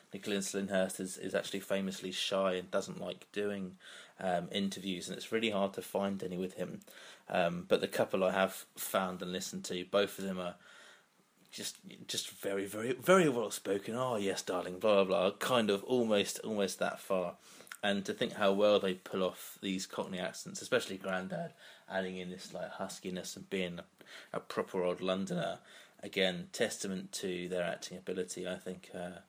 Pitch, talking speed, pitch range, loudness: 95 Hz, 180 wpm, 90-100 Hz, -35 LUFS